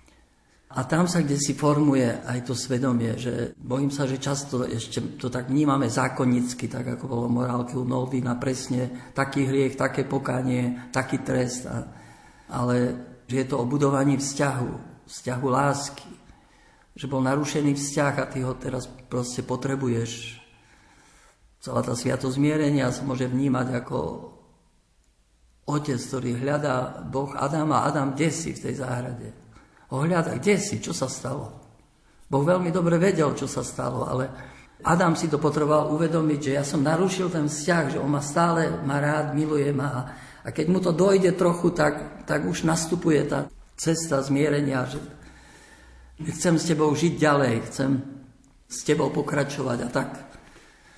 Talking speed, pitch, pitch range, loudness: 150 wpm, 135 Hz, 125-150 Hz, -25 LUFS